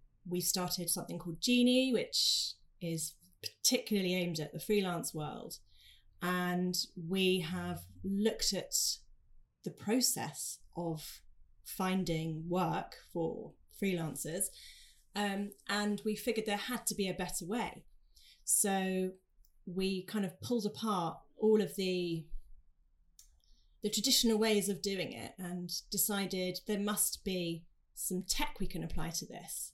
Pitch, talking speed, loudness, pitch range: 185 Hz, 125 wpm, -35 LUFS, 165-205 Hz